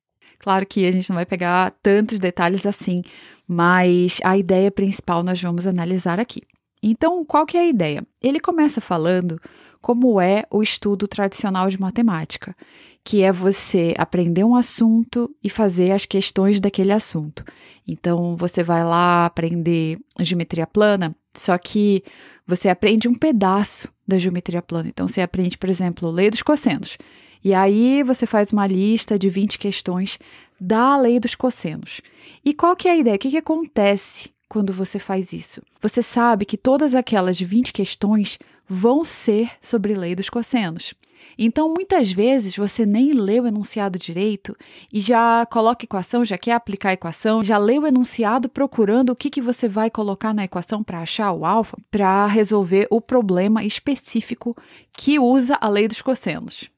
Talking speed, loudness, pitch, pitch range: 165 wpm, -19 LUFS, 205 Hz, 185-235 Hz